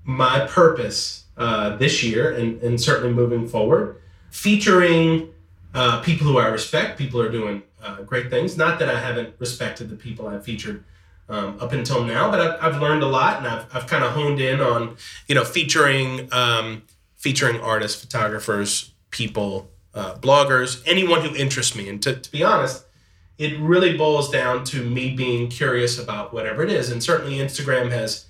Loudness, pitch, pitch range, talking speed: -20 LUFS, 120 Hz, 110-140 Hz, 180 wpm